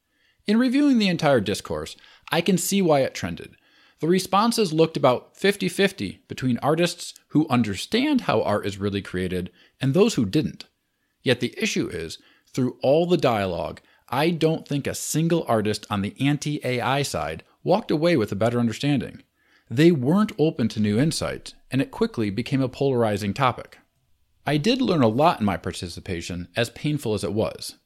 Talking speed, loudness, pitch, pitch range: 175 wpm, -23 LUFS, 140 Hz, 110-175 Hz